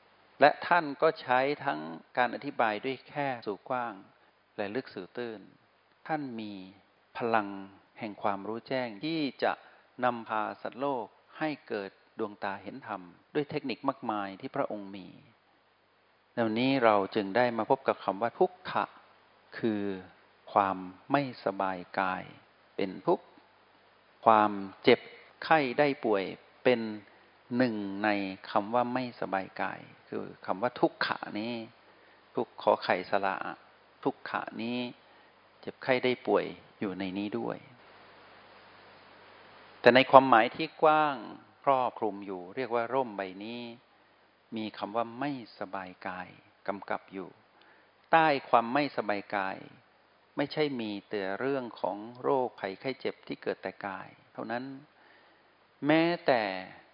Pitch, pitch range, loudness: 115 Hz, 100-135 Hz, -31 LUFS